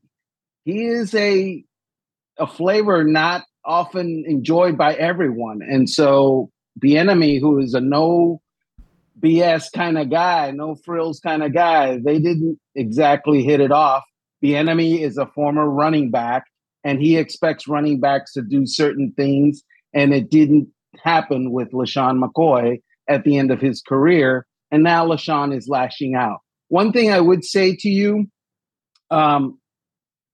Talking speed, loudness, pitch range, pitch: 150 wpm, -18 LUFS, 140-165 Hz, 150 Hz